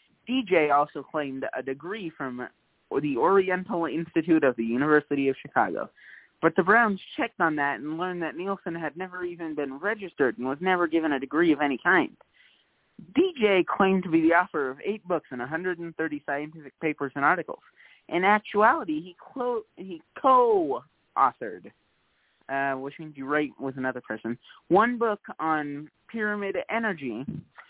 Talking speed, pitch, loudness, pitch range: 150 wpm, 165 Hz, -26 LUFS, 145-200 Hz